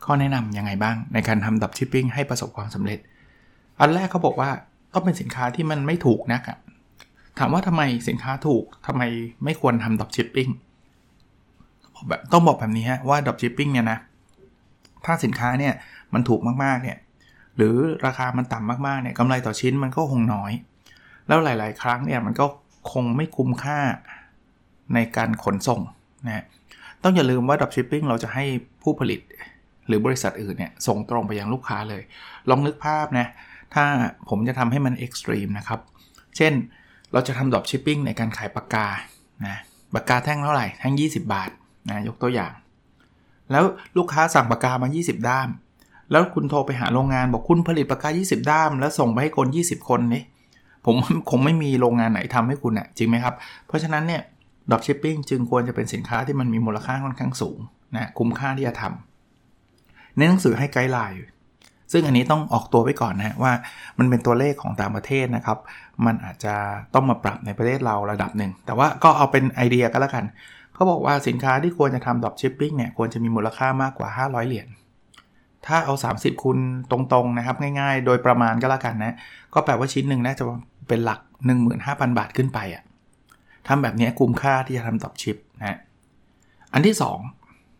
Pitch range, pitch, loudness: 115-140 Hz, 125 Hz, -22 LUFS